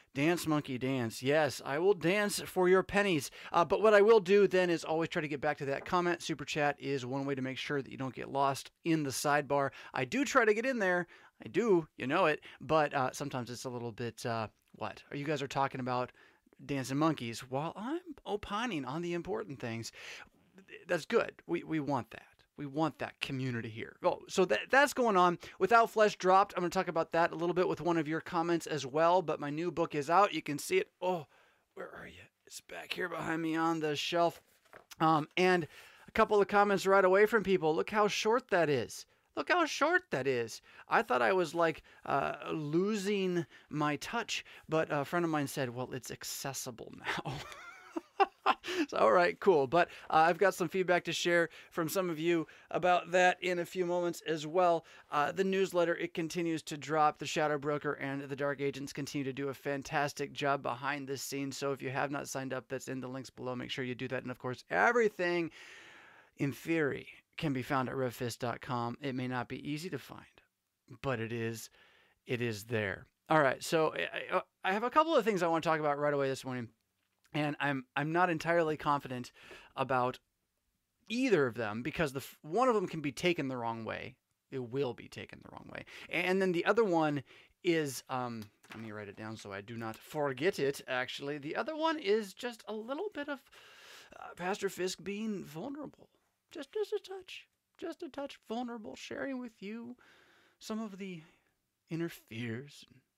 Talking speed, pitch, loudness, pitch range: 210 wpm, 160 Hz, -33 LUFS, 135-190 Hz